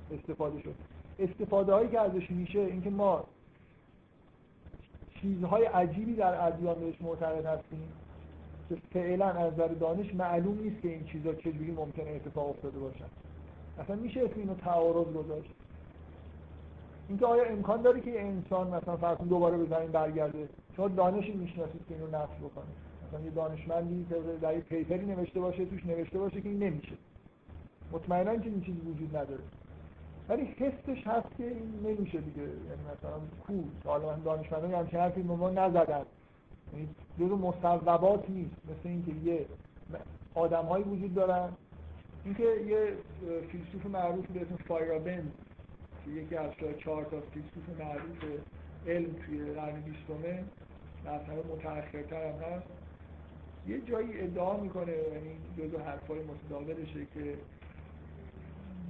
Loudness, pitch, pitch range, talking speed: -34 LUFS, 165 Hz, 145-185 Hz, 140 wpm